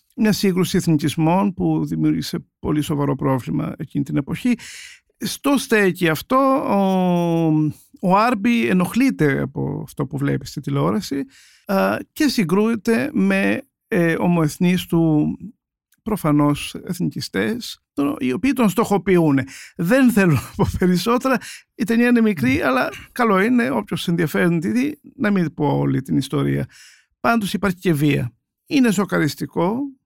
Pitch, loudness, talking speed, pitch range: 180 Hz, -19 LUFS, 125 wpm, 150-230 Hz